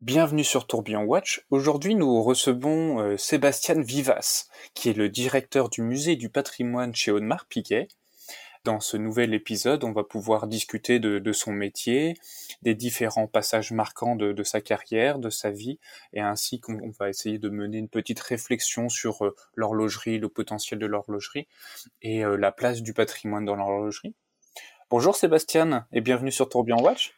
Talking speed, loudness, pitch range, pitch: 170 wpm, -26 LUFS, 105-130 Hz, 115 Hz